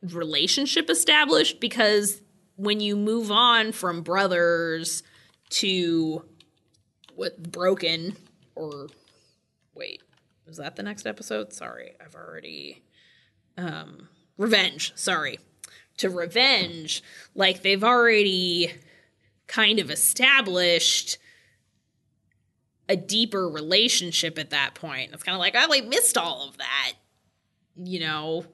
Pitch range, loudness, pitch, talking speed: 165-210 Hz, -22 LUFS, 180 Hz, 110 wpm